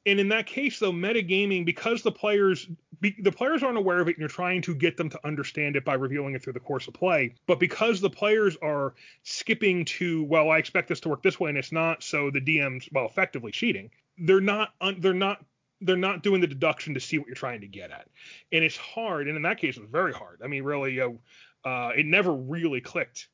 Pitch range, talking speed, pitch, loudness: 145-195 Hz, 245 wpm, 170 Hz, -26 LUFS